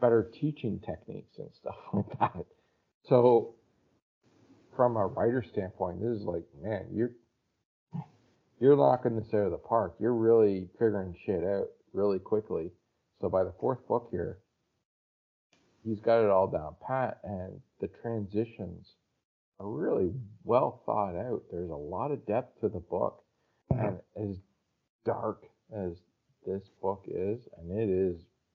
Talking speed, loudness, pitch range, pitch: 145 wpm, -31 LUFS, 90-115 Hz, 105 Hz